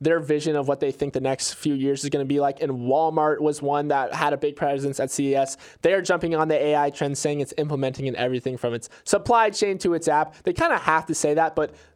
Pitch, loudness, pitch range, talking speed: 145 Hz, -23 LUFS, 140-160 Hz, 265 wpm